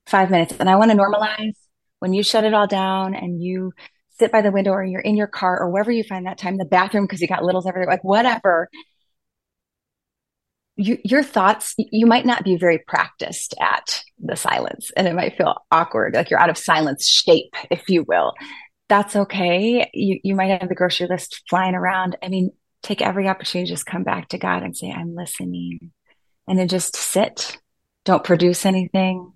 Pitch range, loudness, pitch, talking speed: 180-205 Hz, -19 LUFS, 190 Hz, 200 wpm